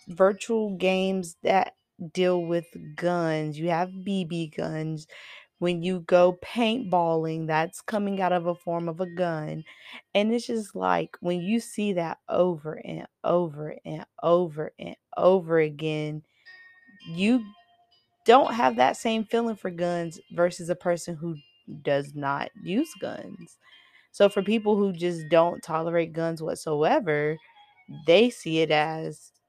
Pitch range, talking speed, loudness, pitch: 160-200 Hz, 140 wpm, -26 LUFS, 175 Hz